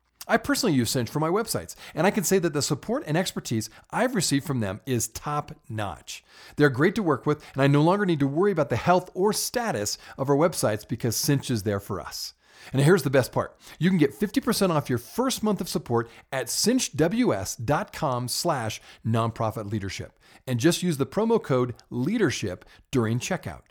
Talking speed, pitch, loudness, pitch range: 195 wpm, 145 Hz, -25 LUFS, 120-180 Hz